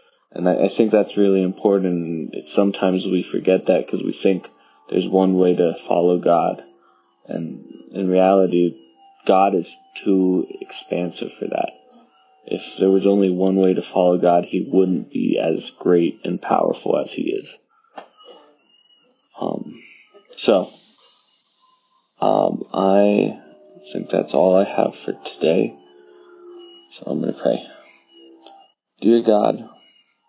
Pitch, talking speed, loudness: 95 Hz, 130 wpm, -19 LUFS